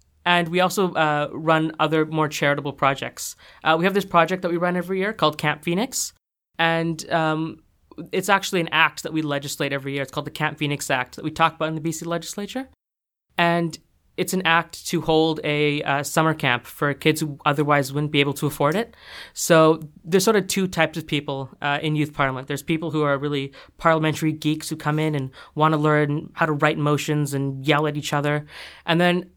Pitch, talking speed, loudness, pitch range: 155 Hz, 210 wpm, -22 LUFS, 145-165 Hz